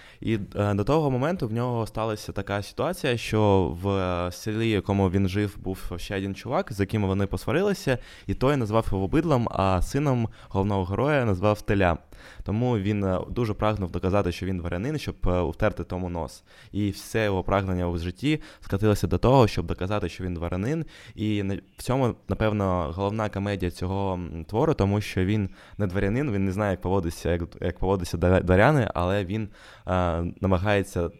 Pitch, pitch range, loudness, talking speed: 100 Hz, 90-110 Hz, -26 LUFS, 165 wpm